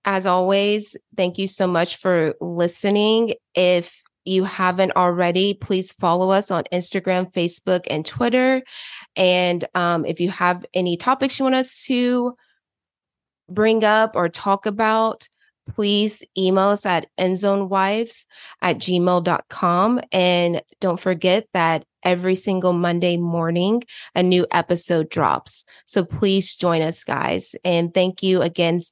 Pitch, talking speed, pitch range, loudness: 185 Hz, 135 wpm, 175-200 Hz, -19 LUFS